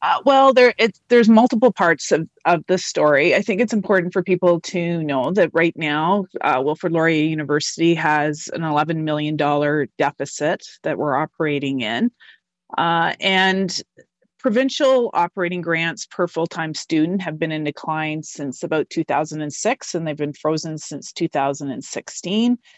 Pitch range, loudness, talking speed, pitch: 150-190 Hz, -19 LUFS, 150 wpm, 165 Hz